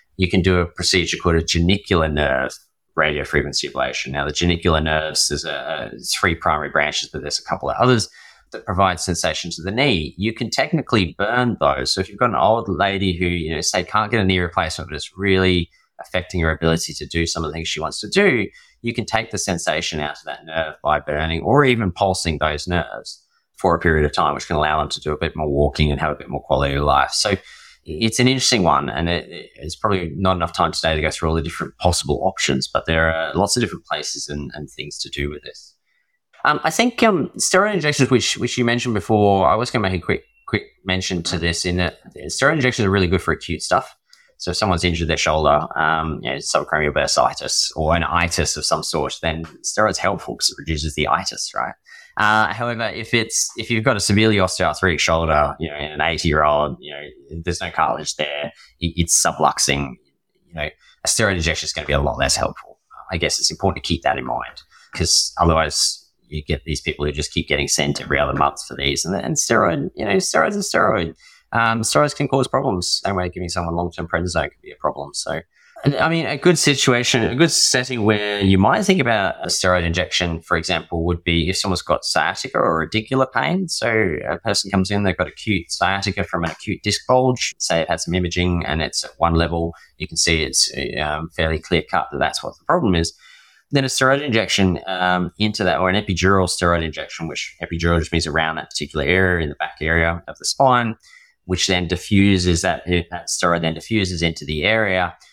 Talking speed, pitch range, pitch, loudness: 225 wpm, 80-105 Hz, 90 Hz, -19 LUFS